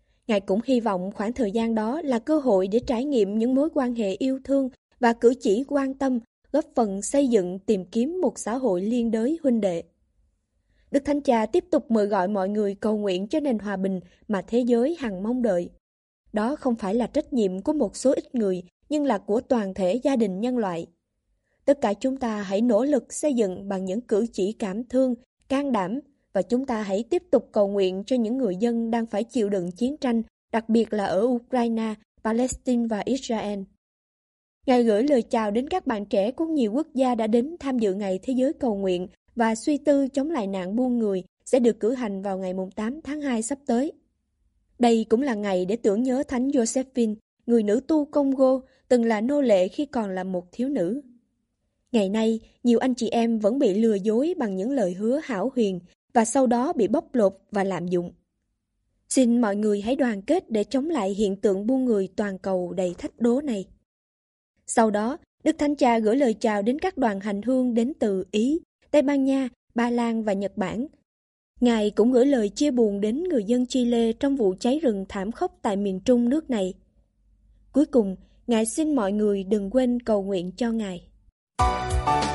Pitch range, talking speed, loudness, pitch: 200-260 Hz, 210 wpm, -24 LUFS, 230 Hz